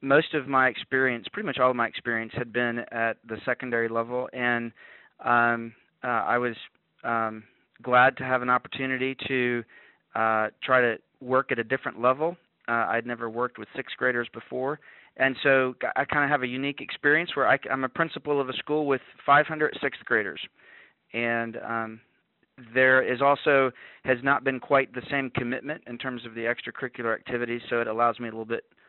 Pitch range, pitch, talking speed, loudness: 115-130 Hz, 125 Hz, 185 wpm, -26 LUFS